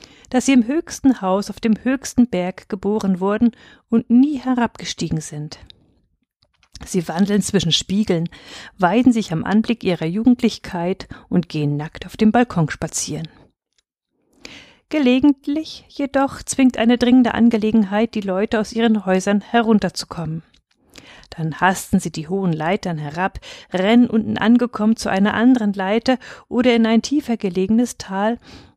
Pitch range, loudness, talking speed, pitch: 185-240 Hz, -19 LUFS, 135 wpm, 215 Hz